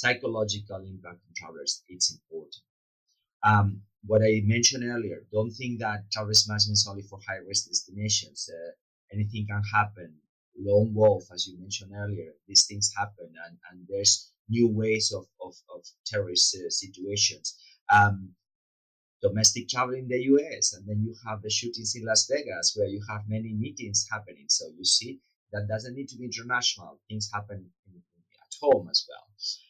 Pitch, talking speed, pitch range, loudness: 105 Hz, 165 wpm, 100-110 Hz, -26 LUFS